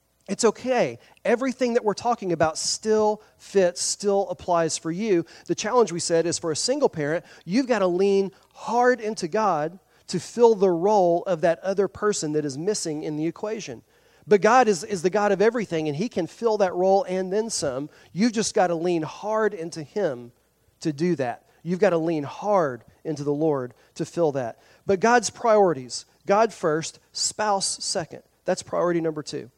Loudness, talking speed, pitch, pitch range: -24 LUFS, 190 wpm, 185 Hz, 160-215 Hz